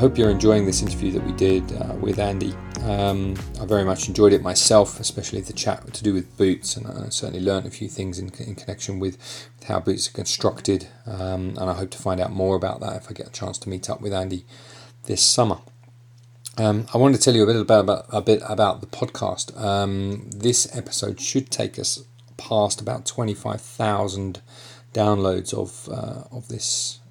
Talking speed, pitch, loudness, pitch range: 205 wpm, 105 Hz, -22 LUFS, 95-120 Hz